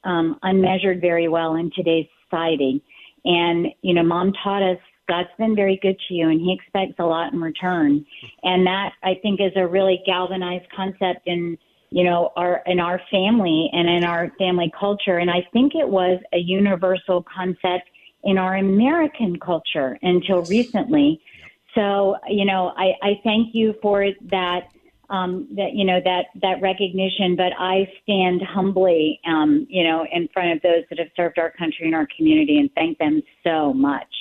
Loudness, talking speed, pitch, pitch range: -20 LUFS, 175 wpm, 185 Hz, 175-195 Hz